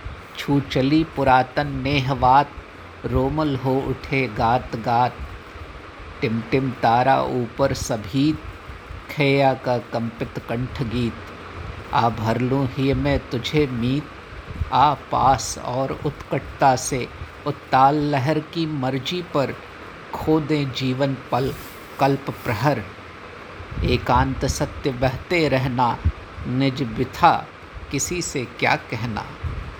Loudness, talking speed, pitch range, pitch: -22 LUFS, 100 wpm, 115-140 Hz, 130 Hz